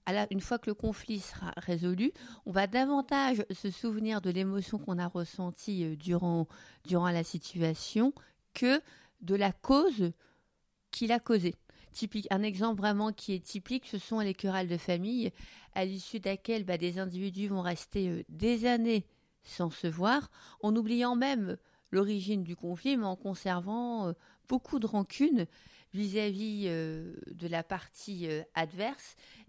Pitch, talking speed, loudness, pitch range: 200 Hz, 155 wpm, -33 LUFS, 180-225 Hz